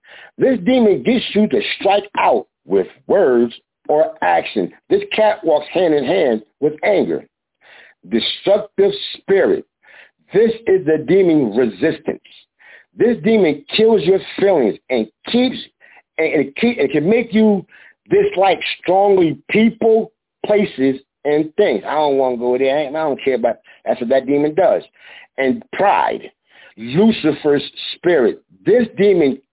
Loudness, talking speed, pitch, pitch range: -16 LUFS, 135 wpm, 195 Hz, 145-225 Hz